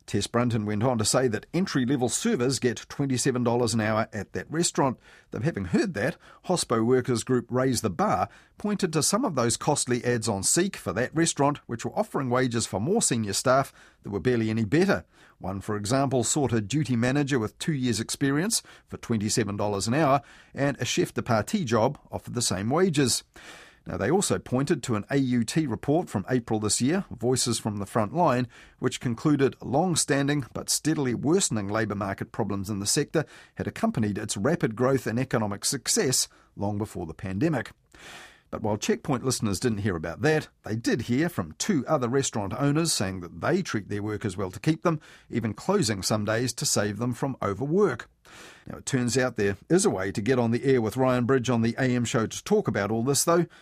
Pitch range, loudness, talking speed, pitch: 110-140 Hz, -26 LUFS, 200 wpm, 125 Hz